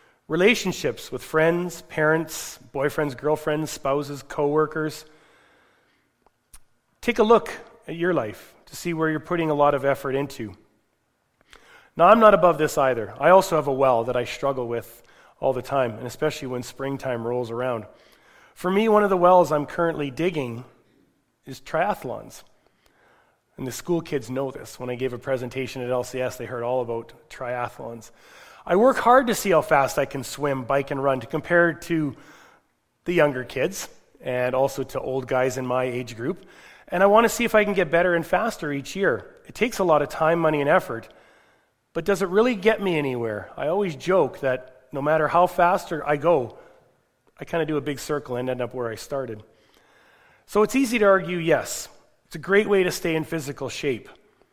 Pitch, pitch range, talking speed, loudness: 145 Hz, 130-170 Hz, 190 wpm, -23 LUFS